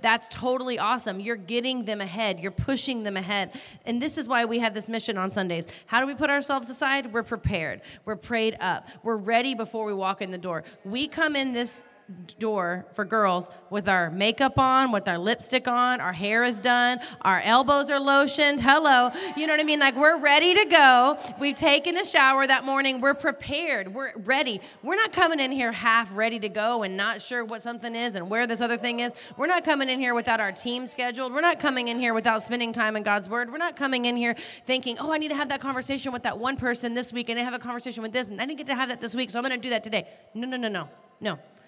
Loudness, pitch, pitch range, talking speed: -24 LUFS, 240 Hz, 220-270 Hz, 250 wpm